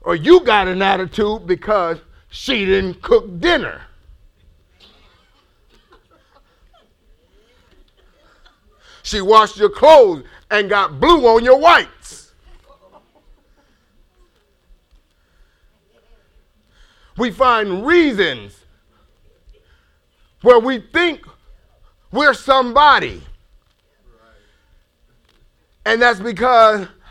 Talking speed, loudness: 70 wpm, -14 LUFS